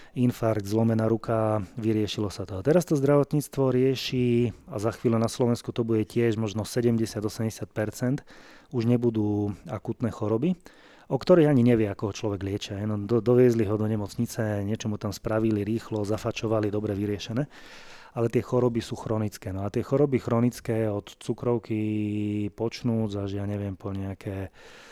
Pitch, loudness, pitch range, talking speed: 110 Hz, -27 LUFS, 105-120 Hz, 155 wpm